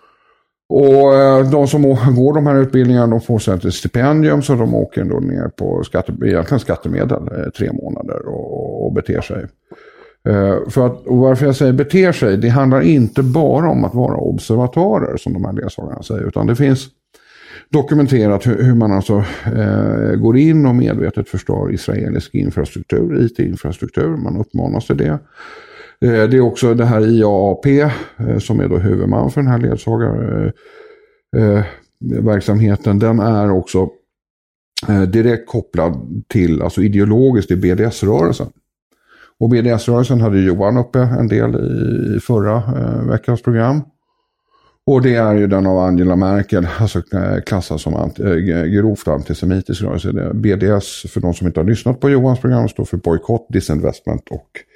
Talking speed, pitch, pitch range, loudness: 145 wpm, 115 Hz, 100-135 Hz, -15 LUFS